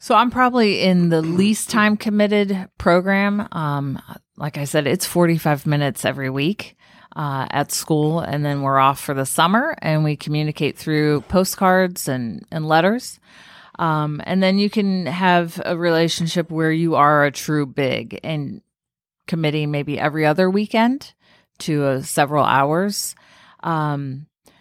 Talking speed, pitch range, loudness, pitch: 150 wpm, 150-190 Hz, -19 LUFS, 165 Hz